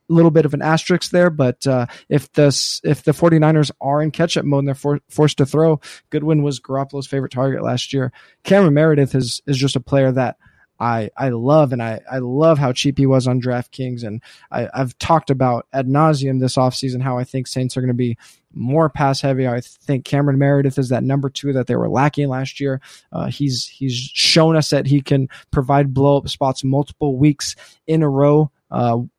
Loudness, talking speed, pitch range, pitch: -17 LUFS, 215 wpm, 130-150 Hz, 140 Hz